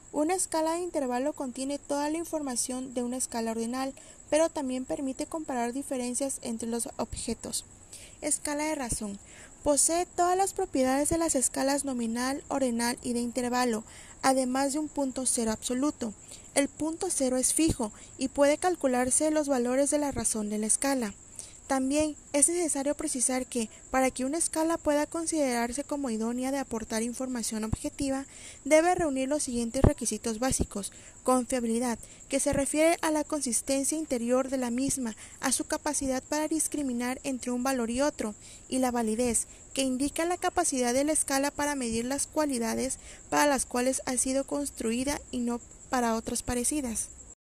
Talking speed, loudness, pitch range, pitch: 160 wpm, -29 LUFS, 245-295 Hz, 270 Hz